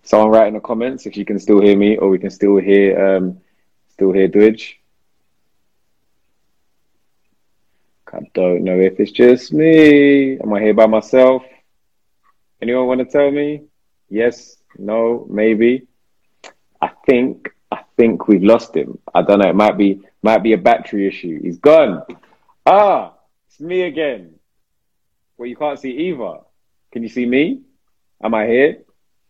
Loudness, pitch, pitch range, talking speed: -14 LUFS, 110 Hz, 100-130 Hz, 155 wpm